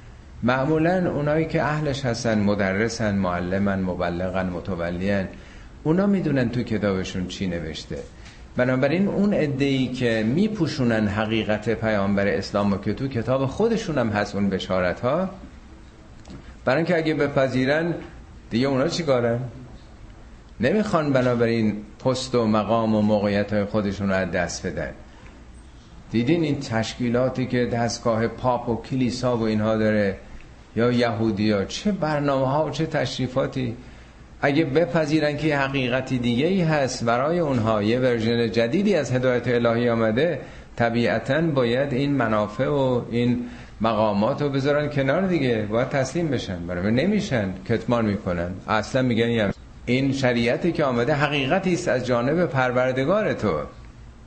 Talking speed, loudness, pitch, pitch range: 135 wpm, -23 LUFS, 120 Hz, 105-140 Hz